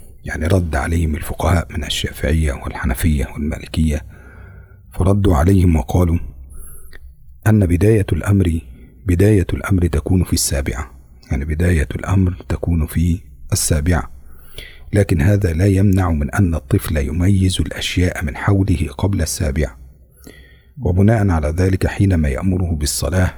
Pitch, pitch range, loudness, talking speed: 85 Hz, 75-95 Hz, -17 LUFS, 115 wpm